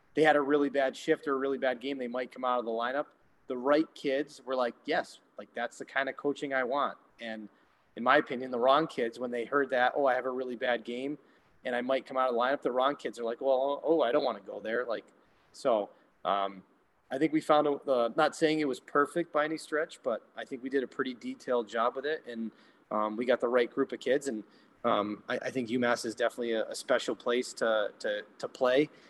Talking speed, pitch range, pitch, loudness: 255 wpm, 120-145 Hz, 130 Hz, -31 LUFS